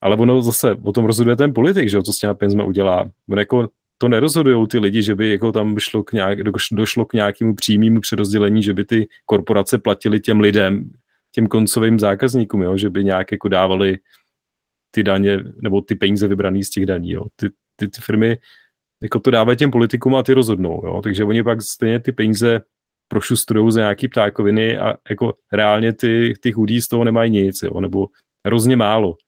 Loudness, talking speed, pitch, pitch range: -17 LUFS, 195 wpm, 110 Hz, 100-115 Hz